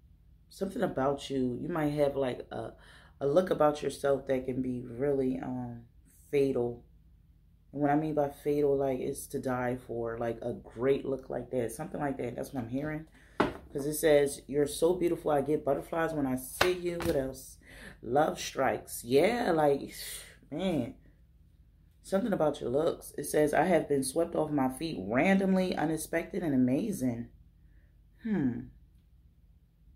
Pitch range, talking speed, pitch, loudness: 120-150 Hz, 160 wpm, 135 Hz, -31 LUFS